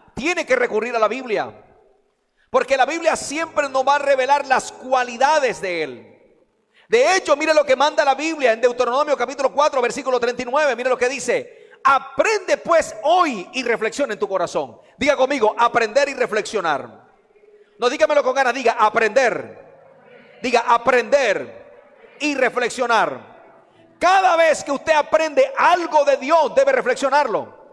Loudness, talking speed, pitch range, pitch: -18 LUFS, 150 wpm, 245-315 Hz, 275 Hz